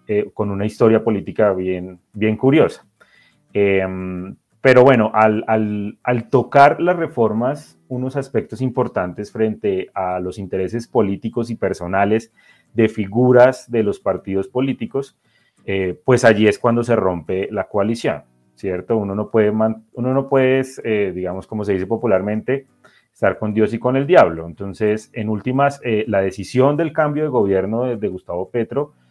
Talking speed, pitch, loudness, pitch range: 160 wpm, 110 Hz, -18 LUFS, 100-125 Hz